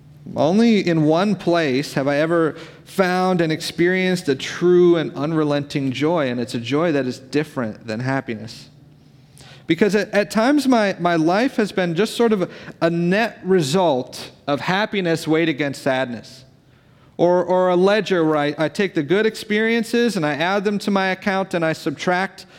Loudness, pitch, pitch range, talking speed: -19 LUFS, 170 Hz, 145-190 Hz, 175 wpm